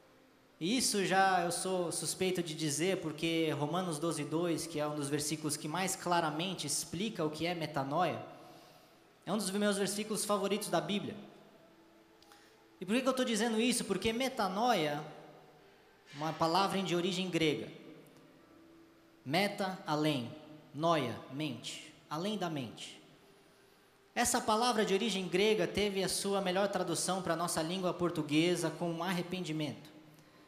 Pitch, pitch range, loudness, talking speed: 175 Hz, 155-195 Hz, -34 LUFS, 140 wpm